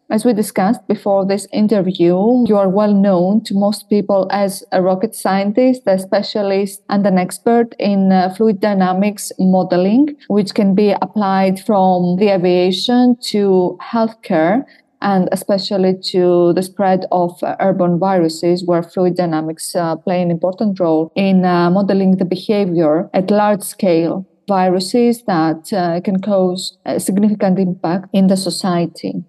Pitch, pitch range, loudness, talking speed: 190 Hz, 180-205 Hz, -15 LUFS, 145 wpm